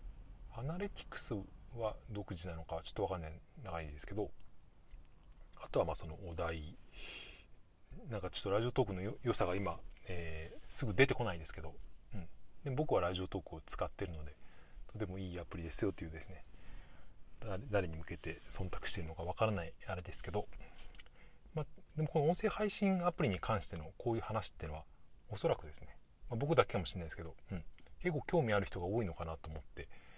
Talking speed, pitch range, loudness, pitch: 370 characters per minute, 80-110 Hz, -40 LUFS, 95 Hz